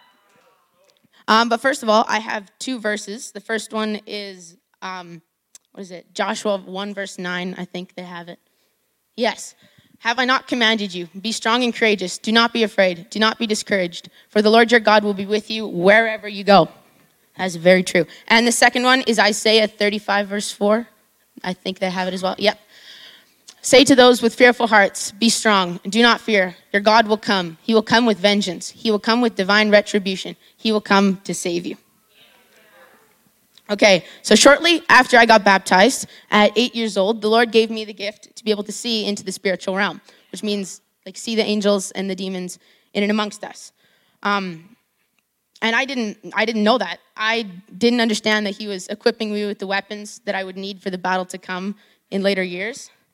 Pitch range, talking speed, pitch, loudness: 195-225 Hz, 200 wpm, 210 Hz, -18 LUFS